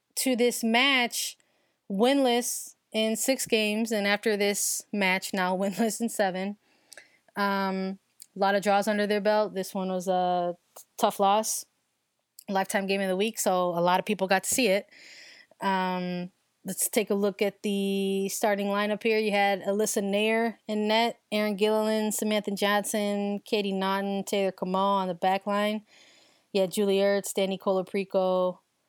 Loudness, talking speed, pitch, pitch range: -27 LUFS, 160 wpm, 205 Hz, 195-220 Hz